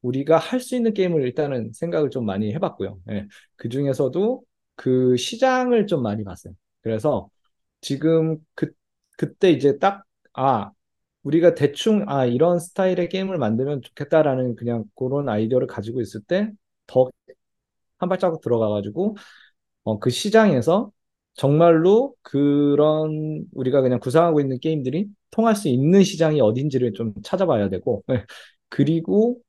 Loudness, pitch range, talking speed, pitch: -21 LUFS, 125-185 Hz, 305 characters per minute, 150 Hz